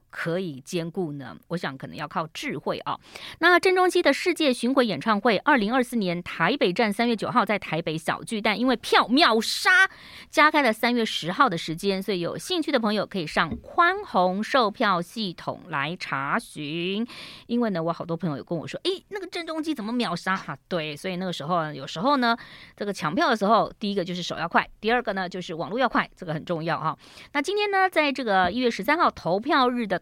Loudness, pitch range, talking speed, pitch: -24 LUFS, 175-265 Hz, 320 characters per minute, 215 Hz